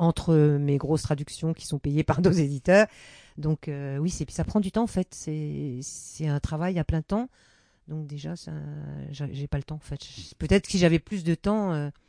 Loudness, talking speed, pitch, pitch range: -27 LUFS, 220 wpm, 155 Hz, 145-175 Hz